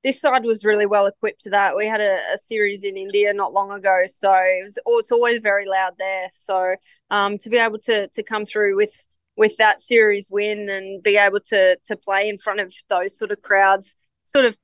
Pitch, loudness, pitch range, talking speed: 205 Hz, -19 LUFS, 195-220 Hz, 225 wpm